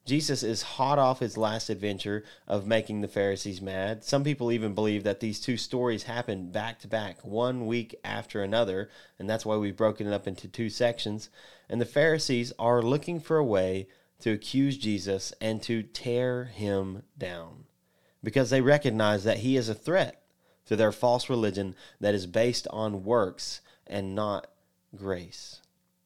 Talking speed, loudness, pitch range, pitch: 170 wpm, -29 LUFS, 105-120 Hz, 110 Hz